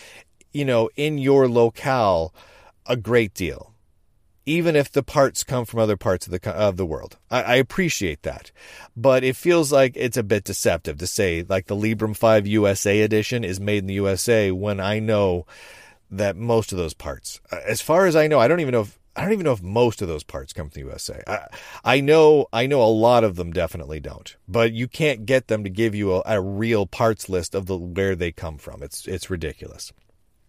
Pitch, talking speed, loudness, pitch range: 110 Hz, 215 wpm, -21 LUFS, 95-120 Hz